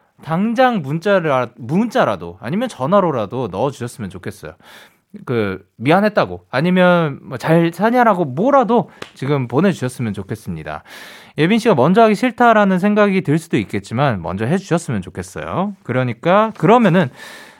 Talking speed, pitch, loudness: 340 characters per minute, 160 Hz, -16 LUFS